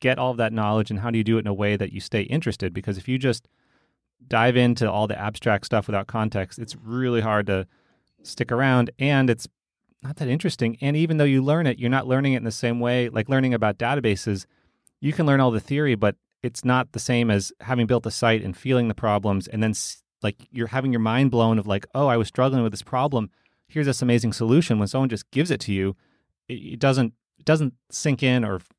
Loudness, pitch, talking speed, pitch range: -23 LUFS, 120 Hz, 240 wpm, 105-130 Hz